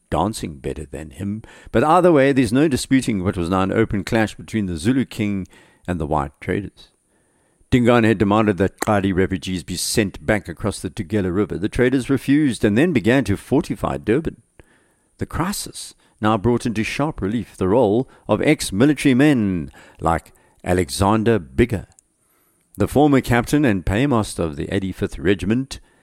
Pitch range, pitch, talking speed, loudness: 95-125 Hz, 105 Hz, 165 wpm, -19 LUFS